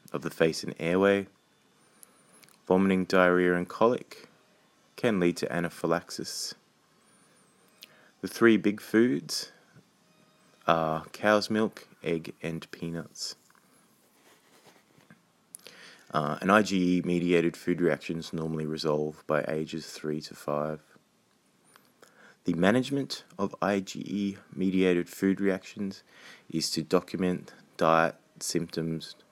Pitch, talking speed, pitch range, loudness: 90 Hz, 100 wpm, 80-95 Hz, -28 LUFS